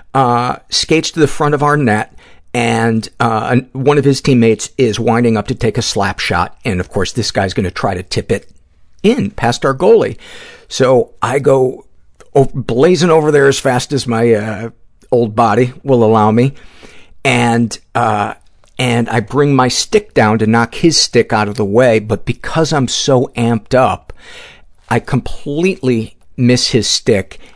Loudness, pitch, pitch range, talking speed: -13 LUFS, 120 Hz, 115-140 Hz, 175 wpm